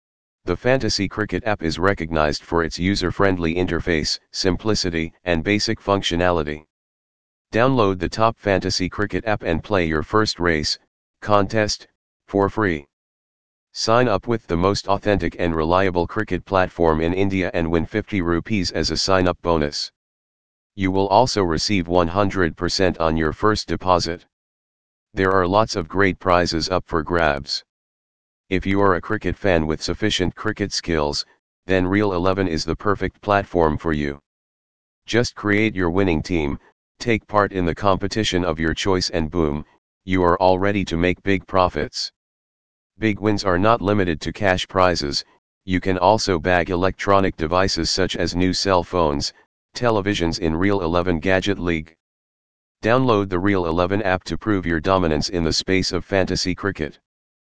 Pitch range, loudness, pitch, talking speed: 85-100 Hz, -20 LUFS, 90 Hz, 155 wpm